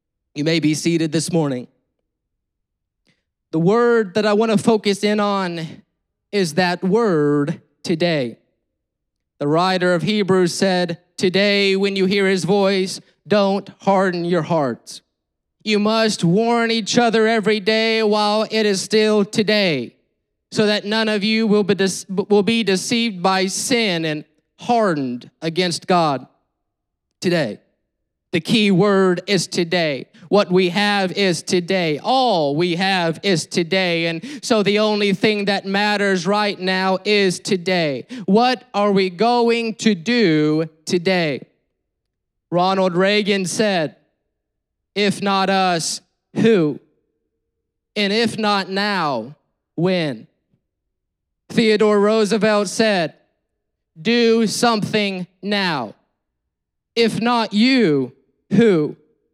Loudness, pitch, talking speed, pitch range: -18 LUFS, 195 Hz, 115 wpm, 170-215 Hz